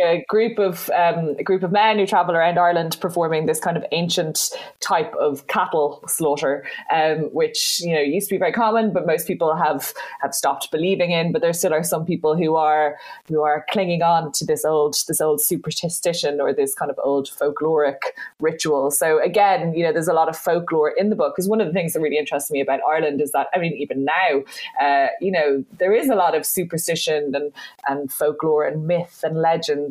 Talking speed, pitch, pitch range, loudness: 215 wpm, 165 Hz, 155-185 Hz, -20 LUFS